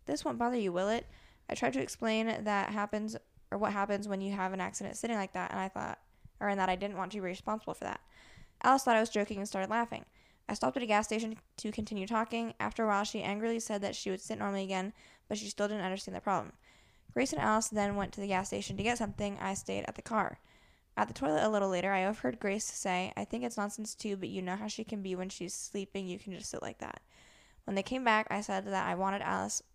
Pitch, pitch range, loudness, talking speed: 200 Hz, 190-220 Hz, -35 LUFS, 265 wpm